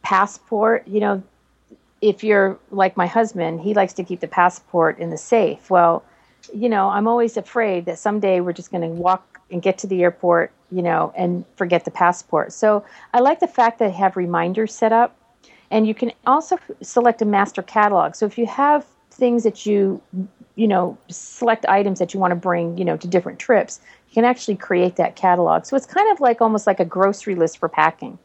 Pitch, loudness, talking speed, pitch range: 195 Hz, -19 LUFS, 210 wpm, 180-230 Hz